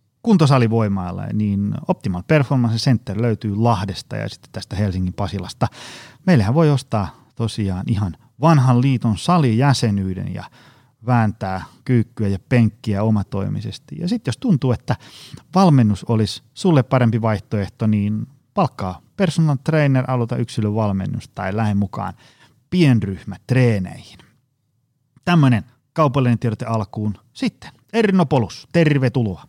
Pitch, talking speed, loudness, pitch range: 120 Hz, 110 wpm, -19 LUFS, 105-135 Hz